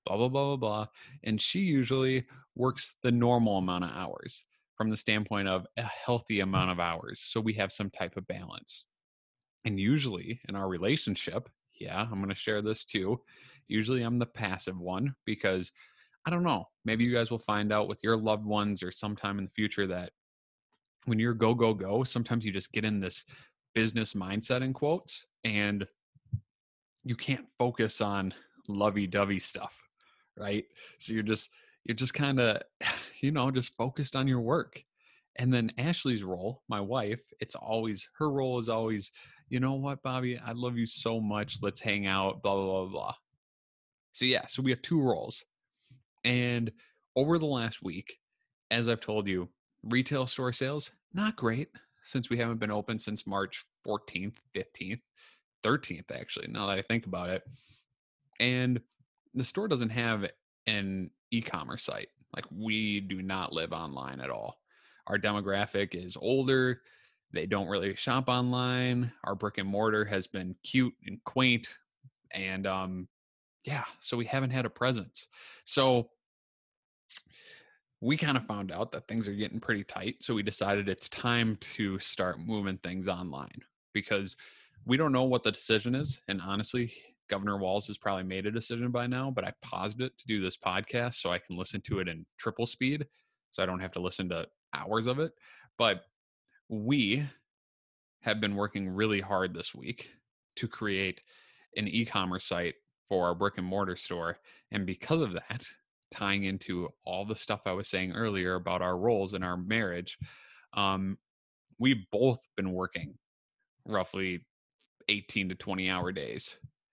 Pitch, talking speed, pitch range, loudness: 110 Hz, 170 wpm, 95-125 Hz, -32 LUFS